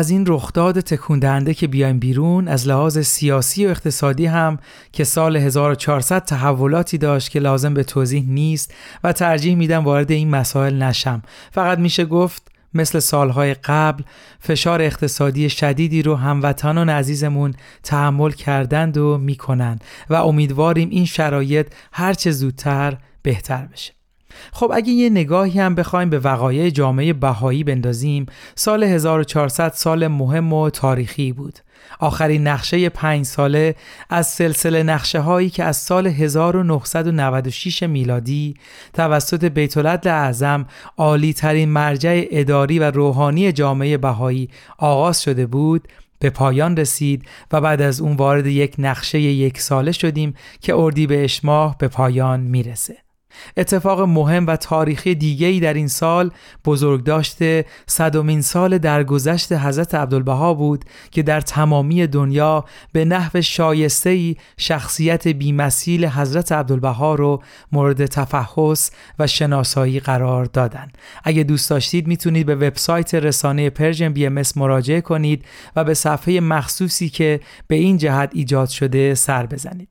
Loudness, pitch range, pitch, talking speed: -17 LUFS, 140-165 Hz, 150 Hz, 135 wpm